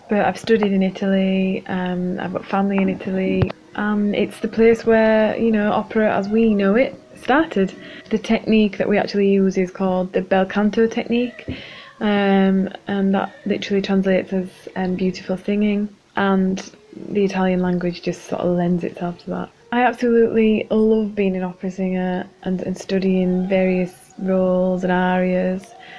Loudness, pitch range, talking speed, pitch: -19 LUFS, 185-215 Hz, 160 wpm, 195 Hz